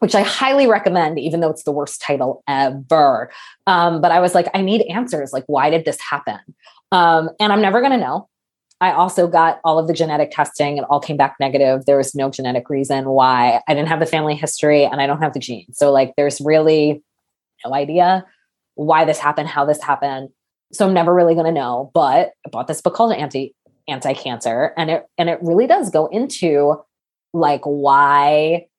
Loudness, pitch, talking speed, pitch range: -16 LUFS, 155 Hz, 210 wpm, 140-175 Hz